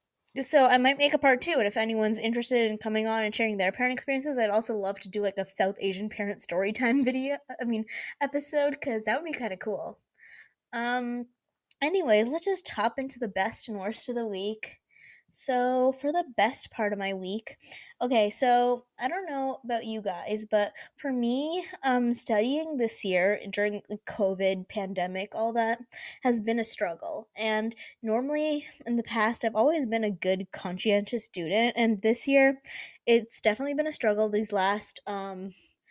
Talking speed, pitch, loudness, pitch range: 185 wpm, 225 Hz, -28 LUFS, 210-260 Hz